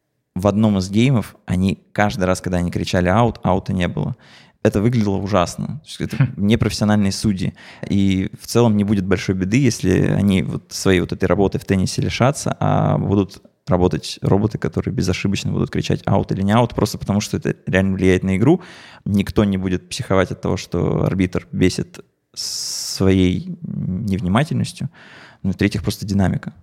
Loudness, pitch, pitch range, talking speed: -19 LUFS, 100 Hz, 95-110 Hz, 160 wpm